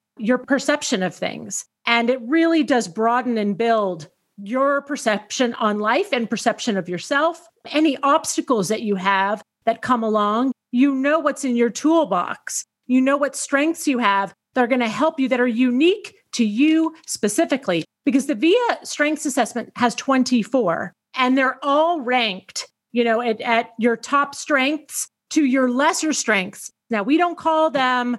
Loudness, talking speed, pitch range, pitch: -20 LUFS, 165 wpm, 225-295 Hz, 255 Hz